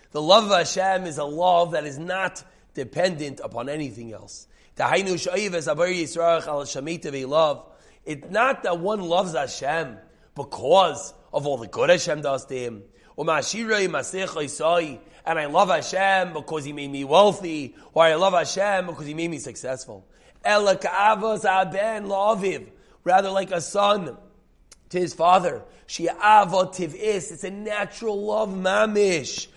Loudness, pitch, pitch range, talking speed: -23 LUFS, 175 Hz, 150-195 Hz, 120 wpm